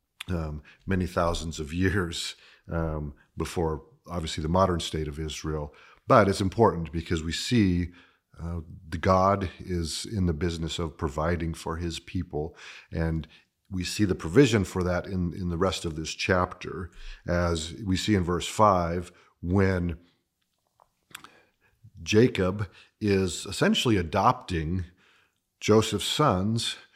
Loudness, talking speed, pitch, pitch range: -27 LUFS, 130 wpm, 90 Hz, 80-95 Hz